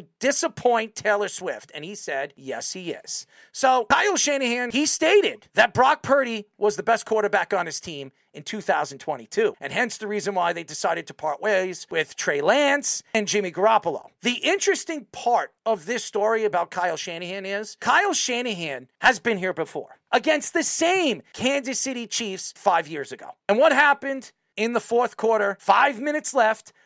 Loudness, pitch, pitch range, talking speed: -23 LUFS, 225 Hz, 200-280 Hz, 170 wpm